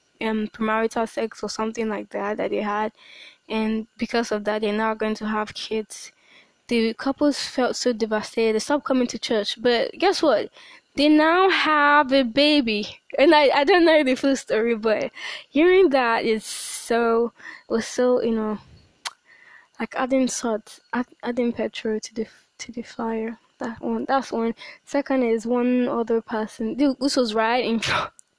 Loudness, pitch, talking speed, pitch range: -22 LUFS, 235 Hz, 170 wpm, 220-270 Hz